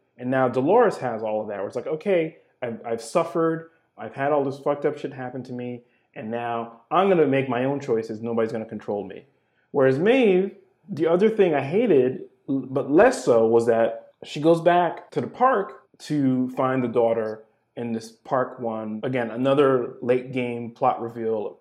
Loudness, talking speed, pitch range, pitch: -23 LUFS, 190 wpm, 115-155 Hz, 130 Hz